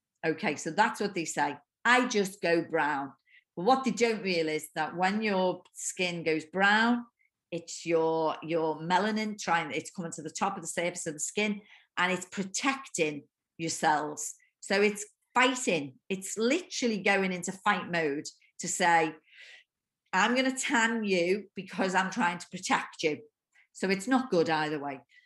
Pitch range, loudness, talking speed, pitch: 165-225 Hz, -29 LUFS, 165 wpm, 190 Hz